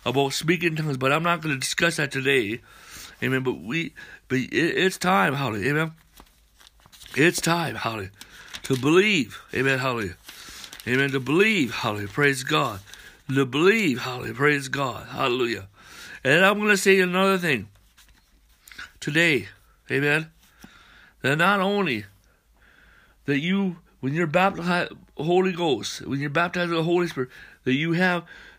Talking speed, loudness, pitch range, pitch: 145 wpm, -23 LUFS, 130-175 Hz, 145 Hz